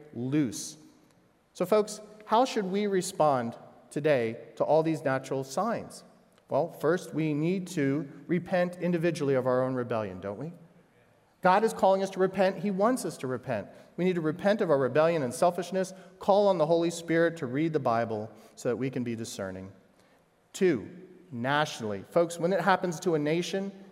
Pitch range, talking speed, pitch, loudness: 135-185 Hz, 175 wpm, 165 Hz, -29 LUFS